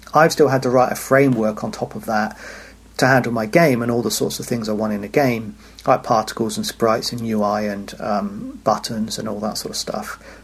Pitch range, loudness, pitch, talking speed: 110-135 Hz, -19 LUFS, 120 Hz, 235 wpm